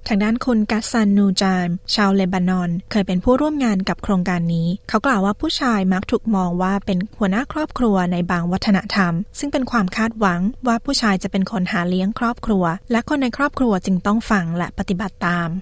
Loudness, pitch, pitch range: -19 LUFS, 200 Hz, 185-230 Hz